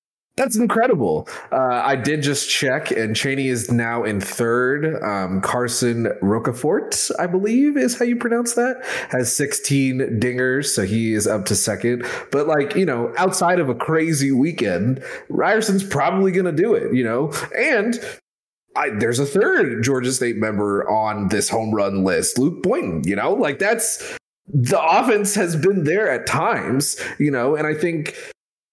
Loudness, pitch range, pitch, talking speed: -19 LUFS, 115-185 Hz, 135 Hz, 165 wpm